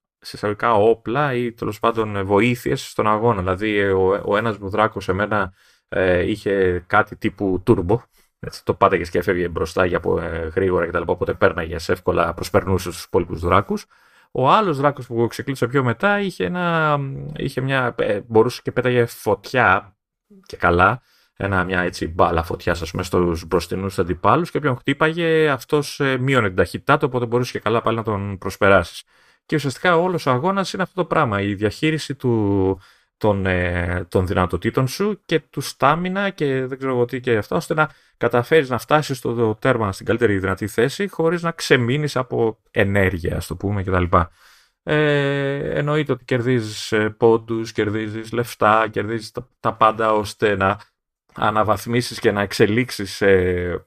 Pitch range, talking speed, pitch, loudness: 100-140 Hz, 155 wpm, 115 Hz, -20 LUFS